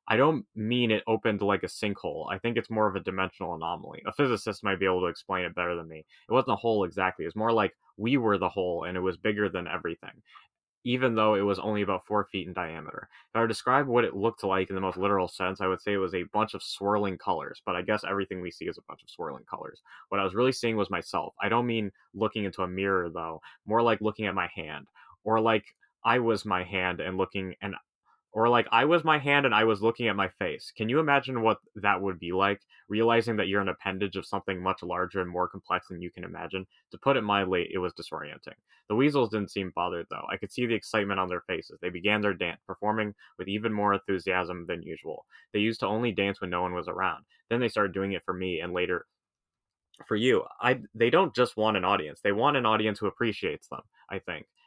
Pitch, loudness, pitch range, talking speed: 100 Hz, -29 LUFS, 95-110 Hz, 250 wpm